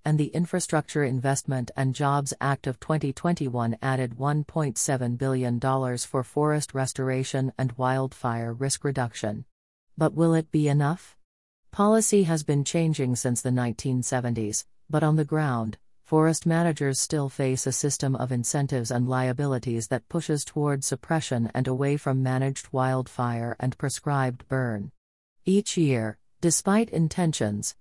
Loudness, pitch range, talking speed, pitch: -26 LUFS, 125-150 Hz, 130 wpm, 135 Hz